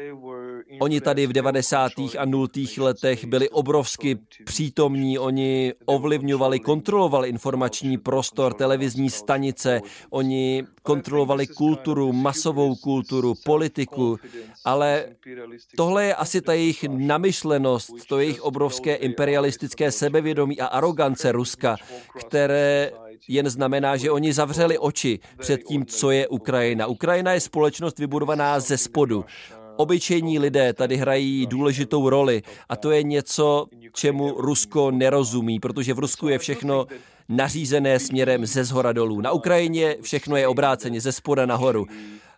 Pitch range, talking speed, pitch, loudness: 130-150 Hz, 125 wpm, 135 Hz, -22 LUFS